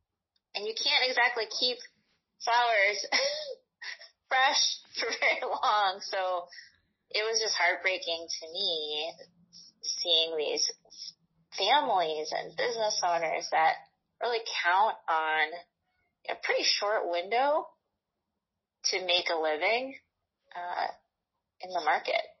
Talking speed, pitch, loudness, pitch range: 105 wpm, 205 Hz, -28 LUFS, 170-270 Hz